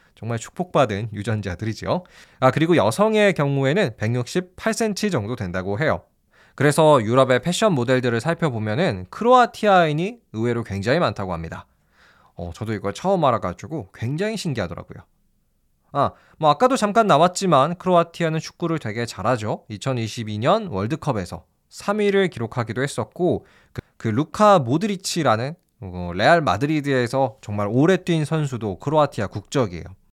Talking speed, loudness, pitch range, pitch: 330 characters per minute, -21 LUFS, 110-175 Hz, 135 Hz